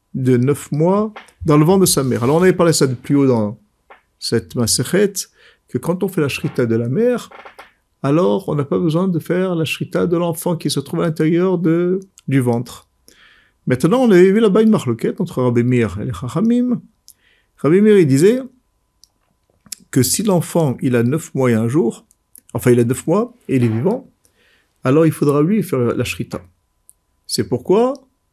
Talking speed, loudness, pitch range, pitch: 195 wpm, -16 LUFS, 125-190 Hz, 160 Hz